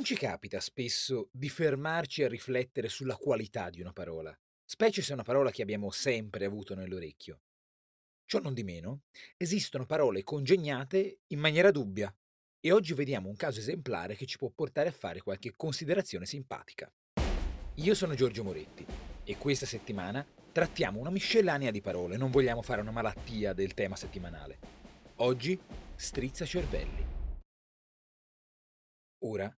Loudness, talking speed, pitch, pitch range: -33 LUFS, 145 wpm, 120 Hz, 95-150 Hz